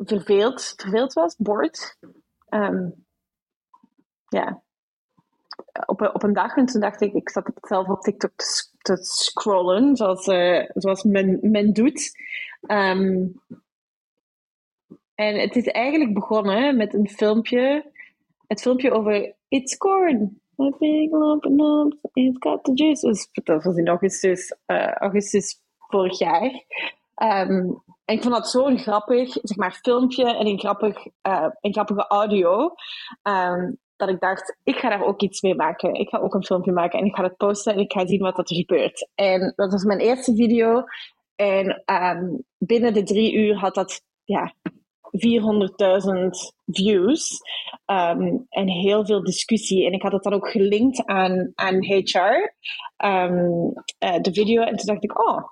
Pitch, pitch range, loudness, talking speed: 210 Hz, 195-245 Hz, -21 LUFS, 155 wpm